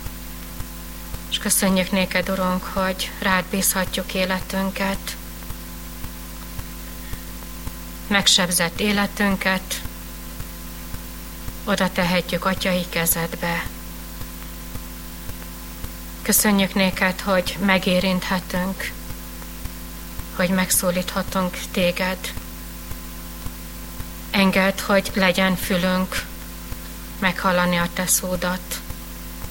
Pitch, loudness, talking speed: 85 Hz, -21 LUFS, 60 wpm